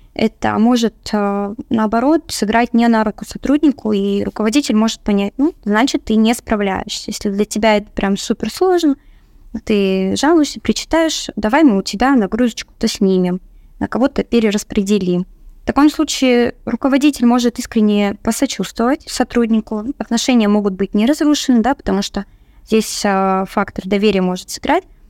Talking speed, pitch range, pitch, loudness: 135 wpm, 205-260 Hz, 225 Hz, -16 LUFS